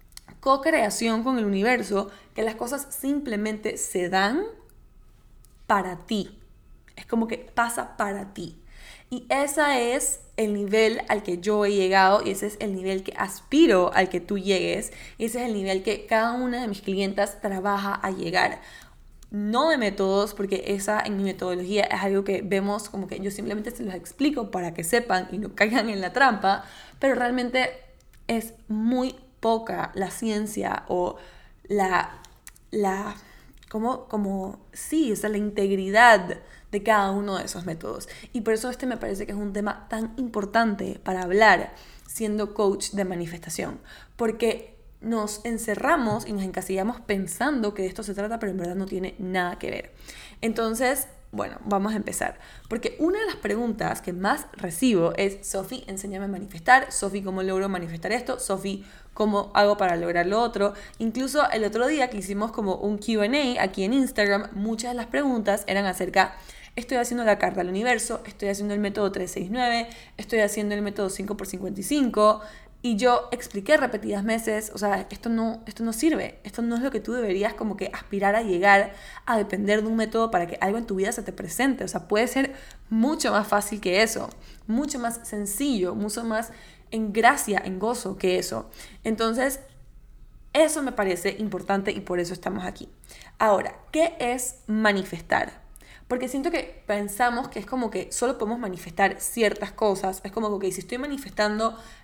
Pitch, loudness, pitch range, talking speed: 210 Hz, -25 LUFS, 195-235 Hz, 175 wpm